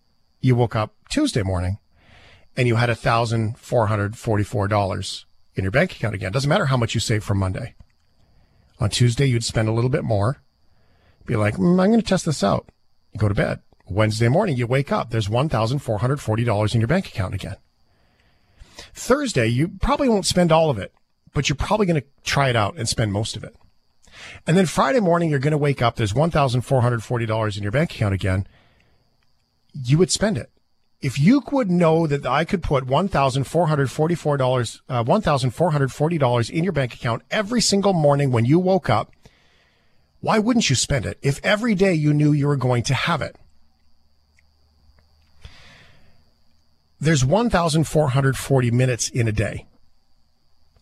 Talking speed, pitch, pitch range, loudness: 185 wpm, 125 Hz, 105-155 Hz, -21 LUFS